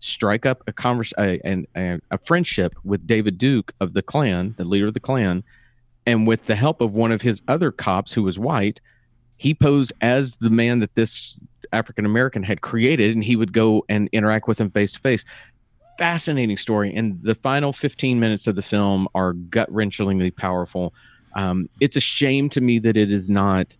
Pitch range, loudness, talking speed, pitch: 100-125 Hz, -20 LUFS, 195 wpm, 110 Hz